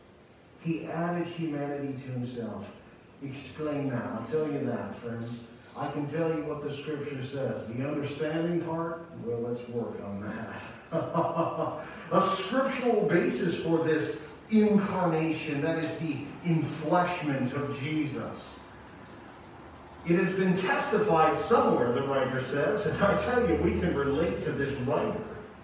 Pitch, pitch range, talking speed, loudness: 155 Hz, 135-165 Hz, 135 wpm, -29 LUFS